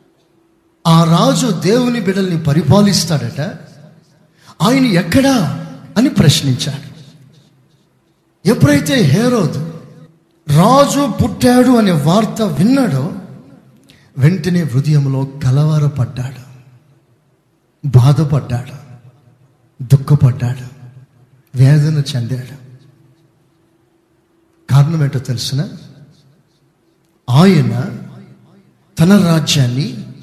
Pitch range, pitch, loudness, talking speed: 135-170 Hz, 150 Hz, -13 LUFS, 60 wpm